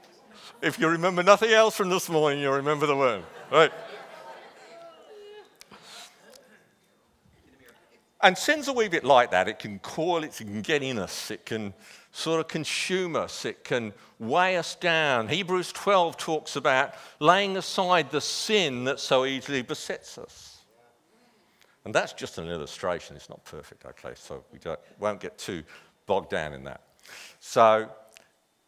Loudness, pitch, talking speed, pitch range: -25 LUFS, 160 Hz, 155 wpm, 130-190 Hz